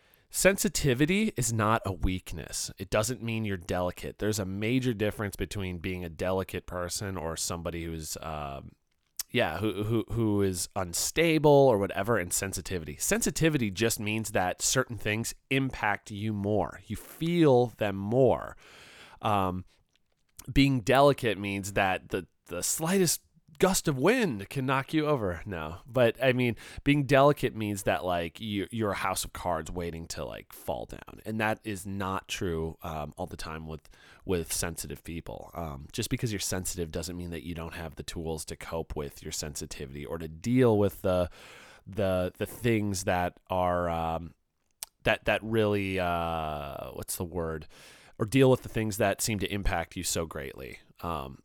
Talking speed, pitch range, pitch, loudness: 165 wpm, 85-115 Hz, 95 Hz, -29 LUFS